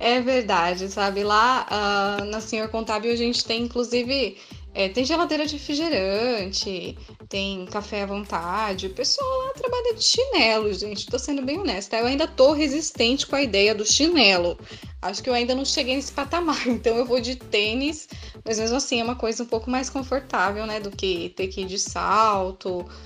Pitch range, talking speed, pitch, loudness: 205-275 Hz, 180 wpm, 235 Hz, -23 LUFS